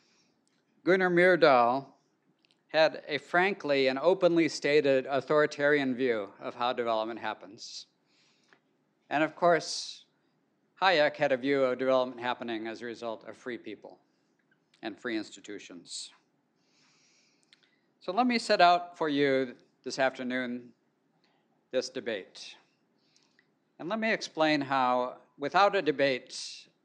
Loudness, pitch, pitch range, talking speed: -28 LUFS, 145 Hz, 130-175 Hz, 115 wpm